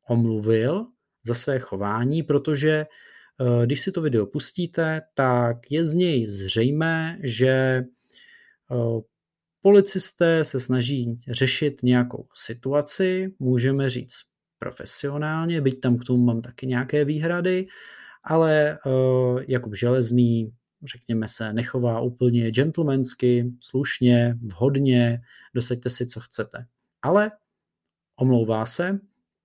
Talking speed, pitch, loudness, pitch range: 100 wpm, 130 Hz, -23 LUFS, 120-155 Hz